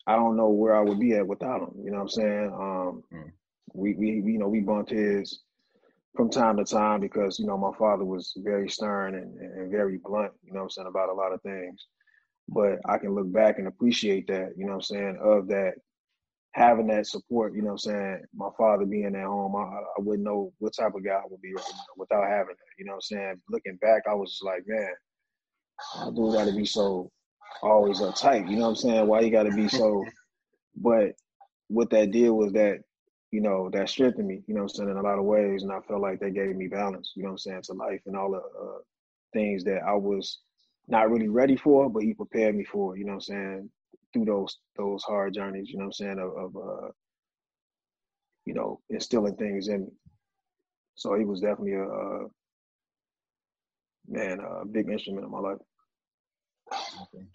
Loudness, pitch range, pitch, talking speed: -27 LUFS, 100-110 Hz, 100 Hz, 220 wpm